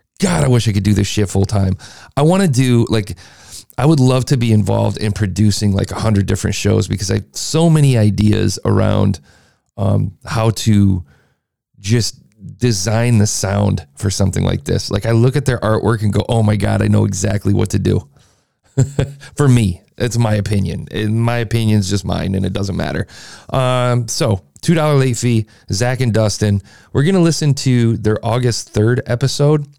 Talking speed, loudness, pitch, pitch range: 190 wpm, -16 LUFS, 110 Hz, 100-125 Hz